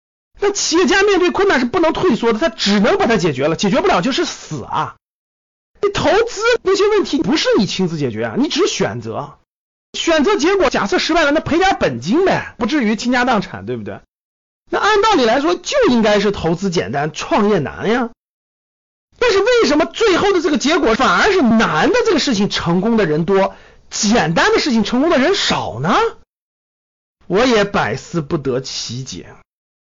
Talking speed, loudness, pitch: 275 characters per minute, -15 LUFS, 270 Hz